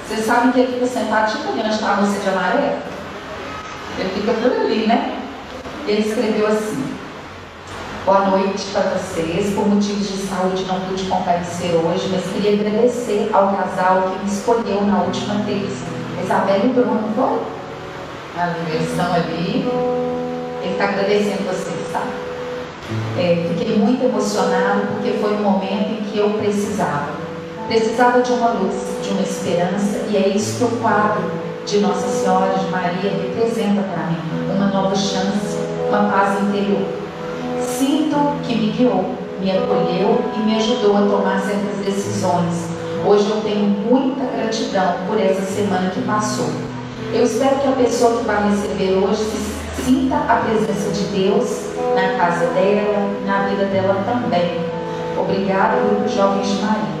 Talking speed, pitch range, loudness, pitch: 155 wpm, 180-225 Hz, -19 LUFS, 205 Hz